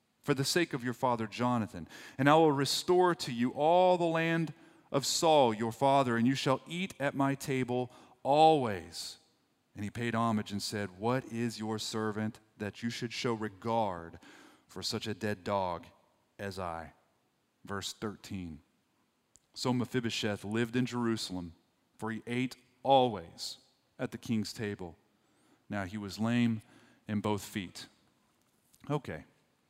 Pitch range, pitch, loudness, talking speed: 105-130 Hz, 115 Hz, -32 LUFS, 145 wpm